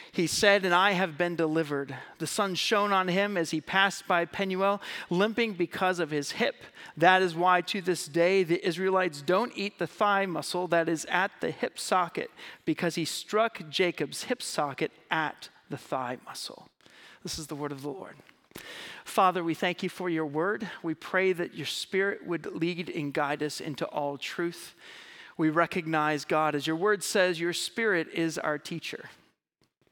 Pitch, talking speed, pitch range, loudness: 175 Hz, 180 wpm, 160-195 Hz, -28 LUFS